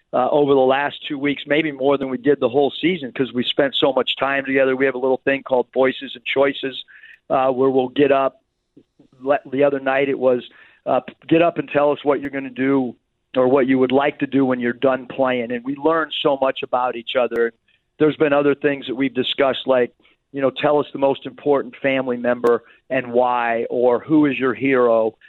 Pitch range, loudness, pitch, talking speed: 130-140 Hz, -19 LUFS, 135 Hz, 225 wpm